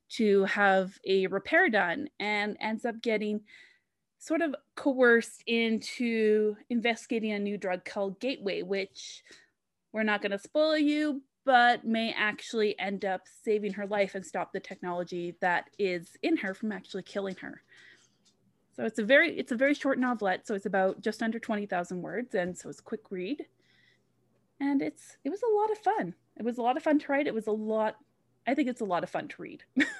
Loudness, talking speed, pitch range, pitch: -30 LUFS, 190 wpm, 195-255 Hz, 215 Hz